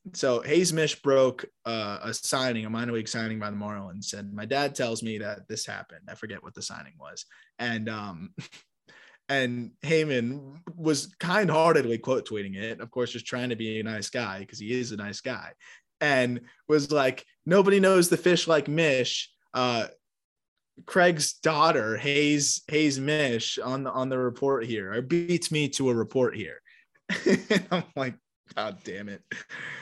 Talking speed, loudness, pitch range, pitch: 175 wpm, -27 LUFS, 115-150 Hz, 130 Hz